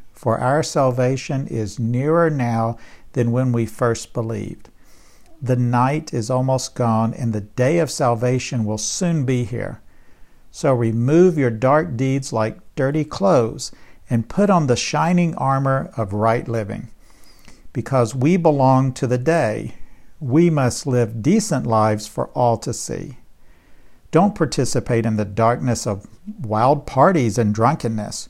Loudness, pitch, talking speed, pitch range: -19 LUFS, 125 Hz, 140 wpm, 115-145 Hz